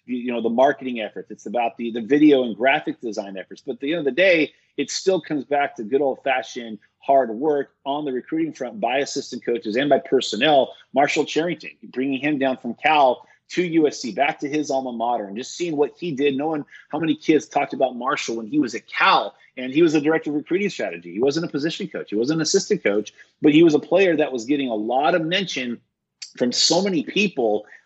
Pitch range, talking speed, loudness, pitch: 125-155 Hz, 230 wpm, -21 LUFS, 140 Hz